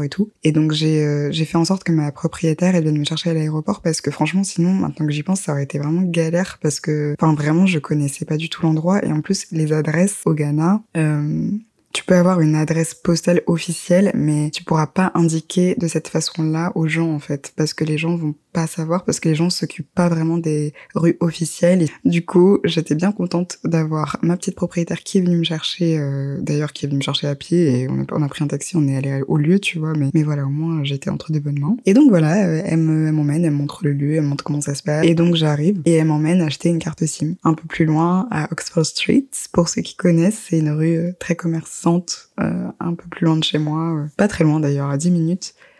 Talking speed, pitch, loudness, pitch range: 255 wpm, 160 Hz, -19 LUFS, 150-175 Hz